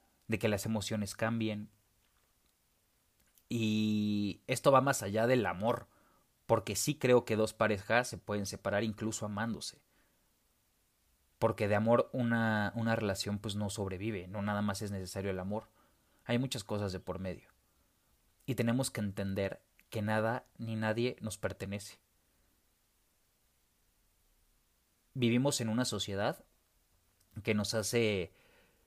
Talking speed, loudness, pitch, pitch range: 130 wpm, -34 LUFS, 105 Hz, 100-115 Hz